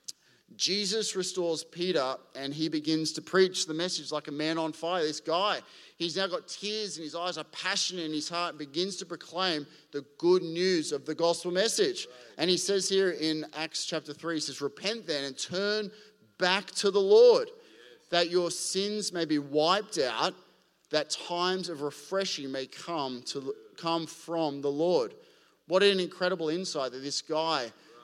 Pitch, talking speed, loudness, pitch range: 170 Hz, 180 wpm, -29 LUFS, 155-190 Hz